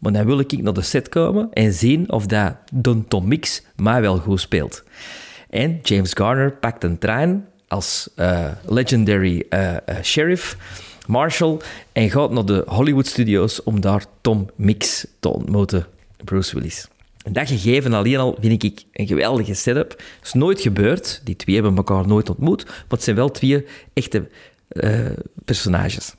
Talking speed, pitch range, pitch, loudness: 170 wpm, 100-130 Hz, 110 Hz, -19 LUFS